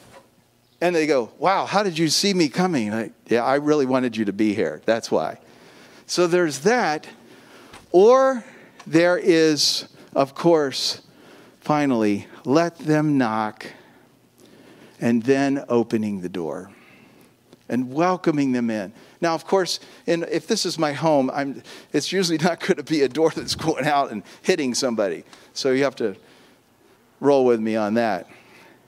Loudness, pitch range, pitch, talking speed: -21 LUFS, 120-170 Hz, 150 Hz, 155 wpm